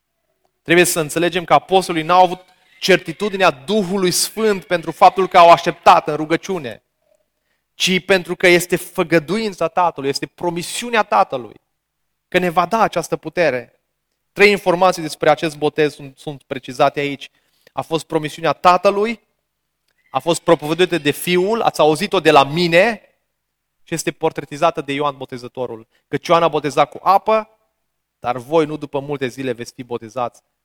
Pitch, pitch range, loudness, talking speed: 165 Hz, 145-185 Hz, -16 LUFS, 150 wpm